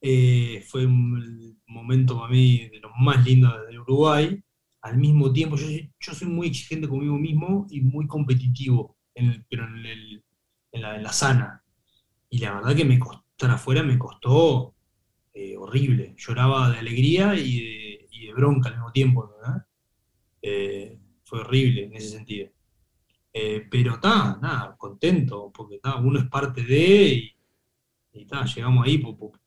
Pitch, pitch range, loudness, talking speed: 125 Hz, 115-135 Hz, -22 LUFS, 165 wpm